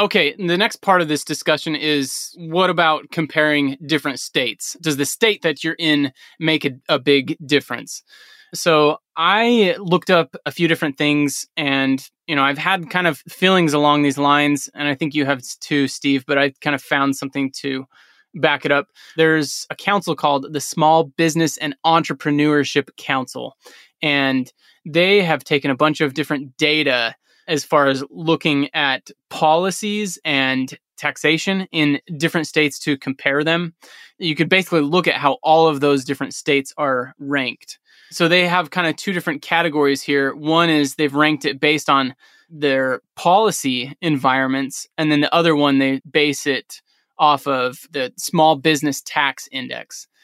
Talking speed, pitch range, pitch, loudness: 165 wpm, 140-165 Hz, 150 Hz, -18 LUFS